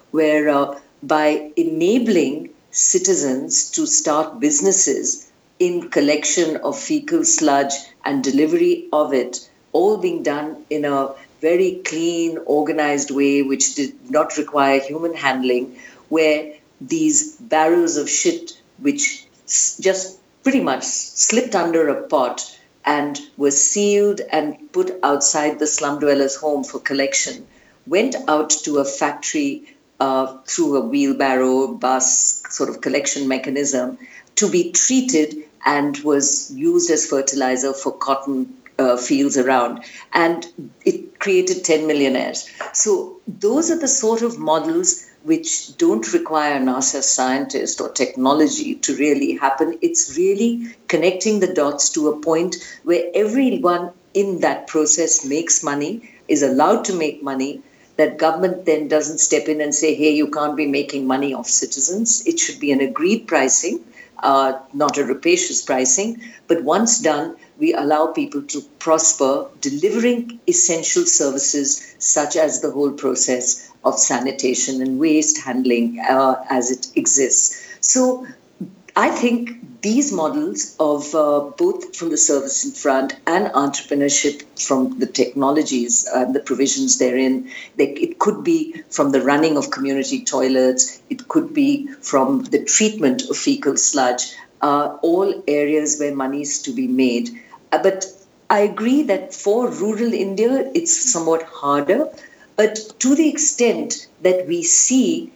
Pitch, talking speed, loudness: 155 Hz, 140 wpm, -18 LUFS